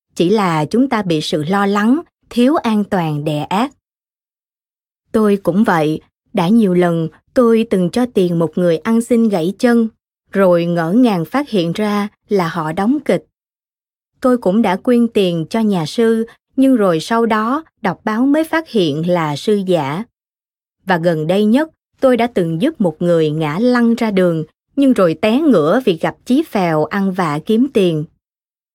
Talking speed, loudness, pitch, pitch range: 175 wpm, -15 LUFS, 205 Hz, 175-235 Hz